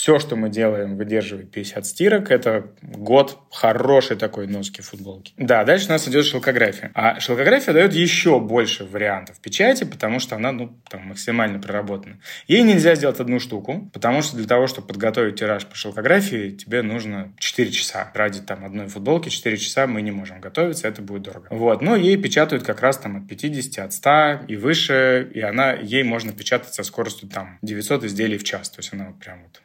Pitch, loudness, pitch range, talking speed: 110 Hz, -19 LUFS, 100-135 Hz, 190 wpm